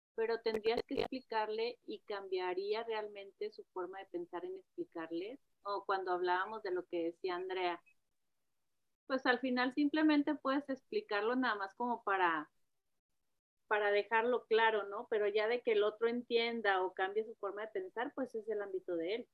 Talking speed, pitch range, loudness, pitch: 170 wpm, 190-245 Hz, -37 LUFS, 215 Hz